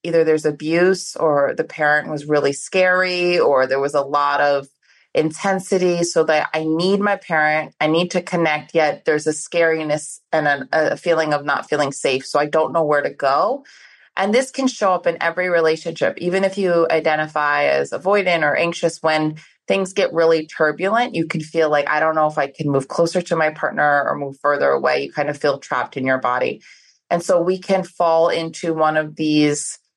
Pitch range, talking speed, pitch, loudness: 150-175 Hz, 205 wpm, 160 Hz, -18 LUFS